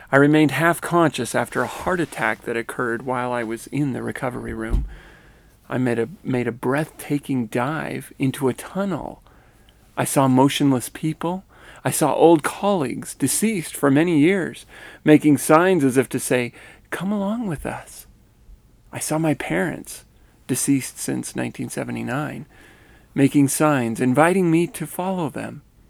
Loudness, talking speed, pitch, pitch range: -21 LUFS, 145 wpm, 140 Hz, 125-160 Hz